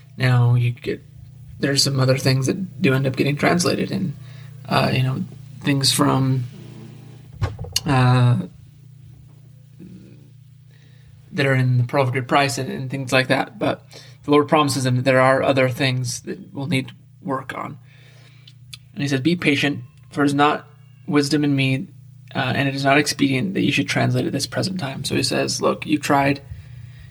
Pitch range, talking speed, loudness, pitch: 130-140 Hz, 180 wpm, -20 LUFS, 135 Hz